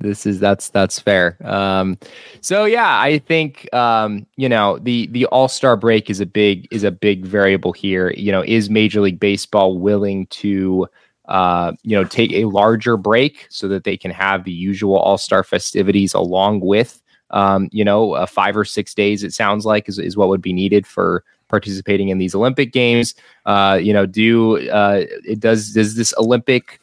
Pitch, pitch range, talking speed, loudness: 100 Hz, 95-110 Hz, 190 wpm, -16 LUFS